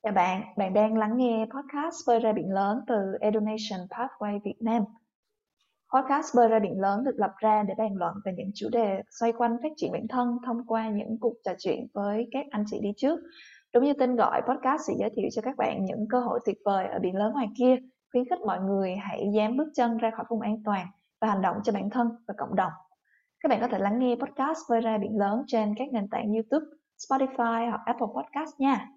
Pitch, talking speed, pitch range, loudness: 225 Hz, 235 wpm, 205-255 Hz, -28 LUFS